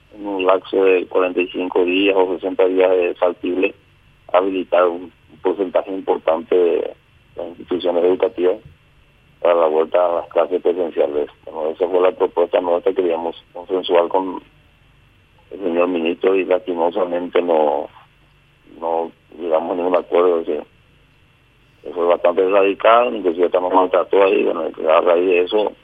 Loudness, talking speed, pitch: -18 LUFS, 140 wpm, 95 Hz